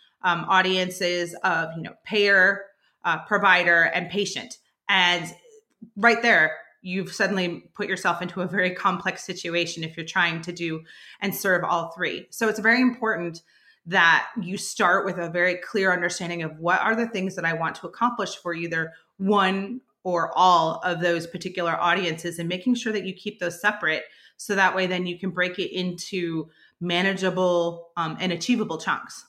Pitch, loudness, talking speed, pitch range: 180 Hz, -23 LUFS, 170 wpm, 170-200 Hz